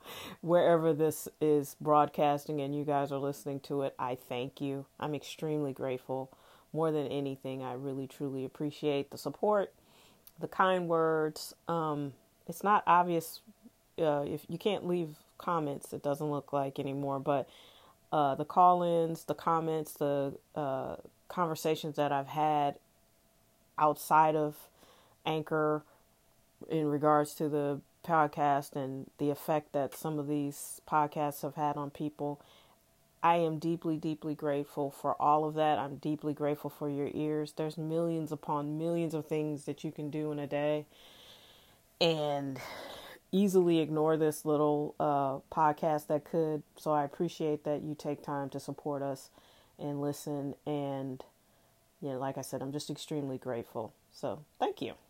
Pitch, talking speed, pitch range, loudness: 150 Hz, 150 wpm, 140-155 Hz, -33 LUFS